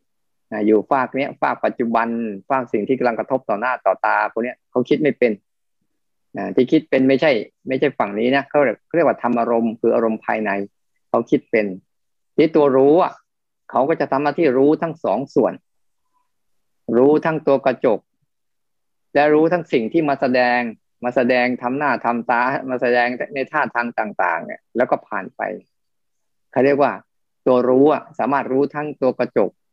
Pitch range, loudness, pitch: 115-145 Hz, -19 LUFS, 130 Hz